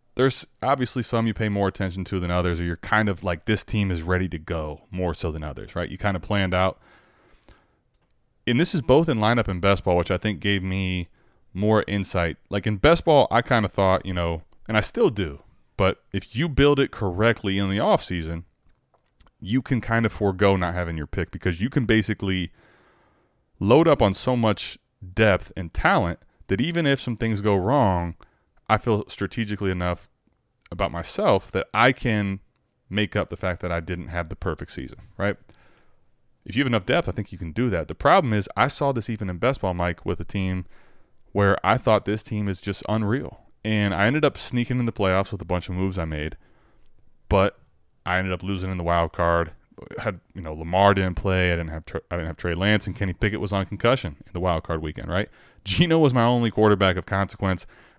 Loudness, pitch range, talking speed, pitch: -23 LUFS, 90-110 Hz, 220 wpm, 100 Hz